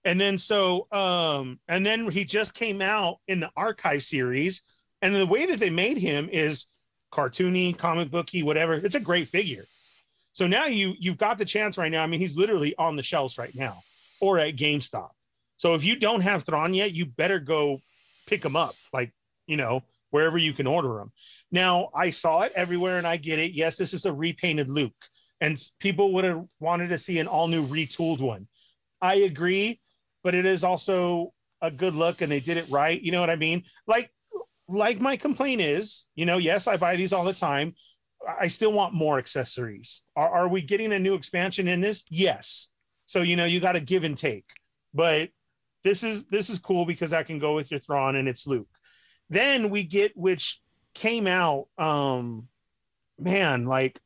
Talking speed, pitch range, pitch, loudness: 200 wpm, 150-195 Hz, 175 Hz, -25 LUFS